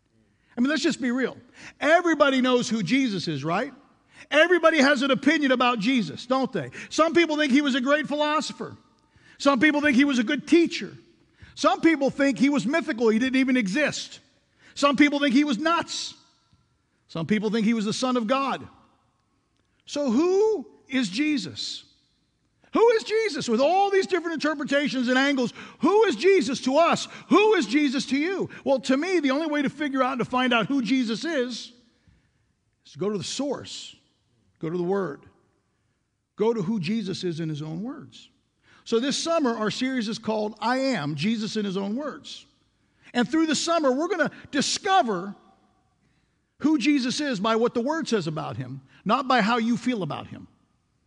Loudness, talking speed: -24 LUFS, 185 wpm